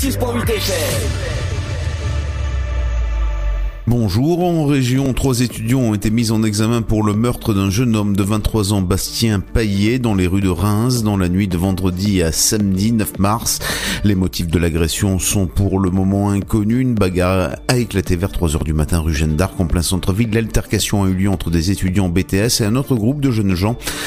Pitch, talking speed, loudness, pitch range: 100 Hz, 180 wpm, -17 LUFS, 90-115 Hz